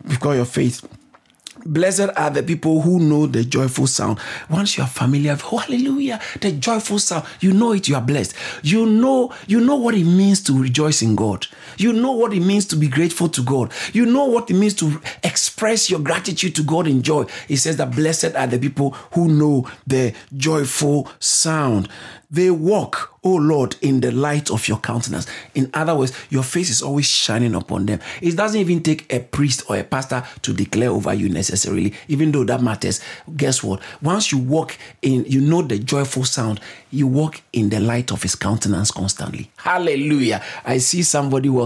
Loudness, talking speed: -18 LUFS, 195 wpm